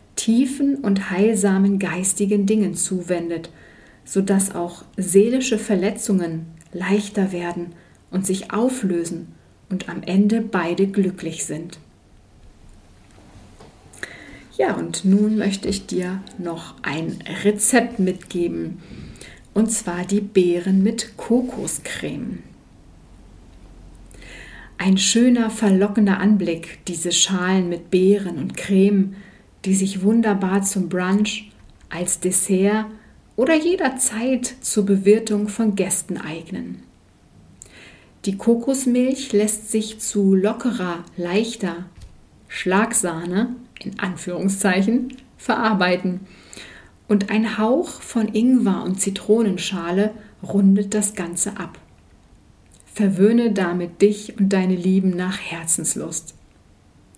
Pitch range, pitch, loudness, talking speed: 175-210 Hz, 195 Hz, -20 LUFS, 95 wpm